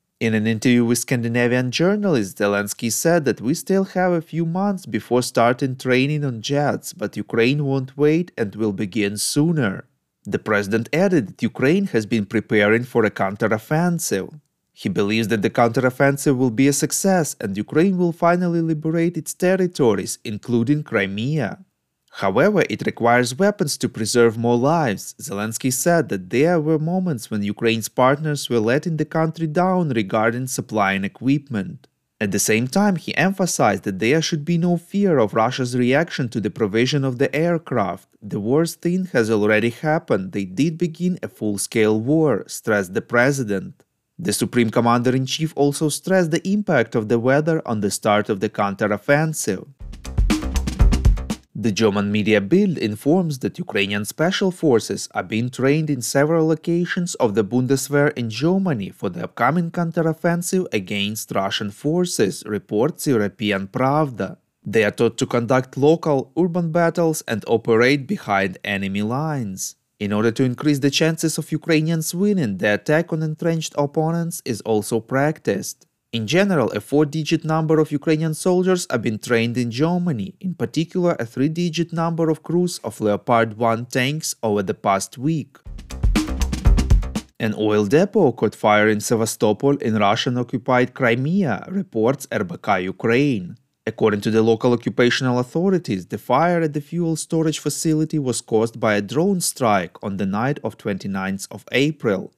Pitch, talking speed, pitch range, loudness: 135 Hz, 155 wpm, 110-160 Hz, -20 LUFS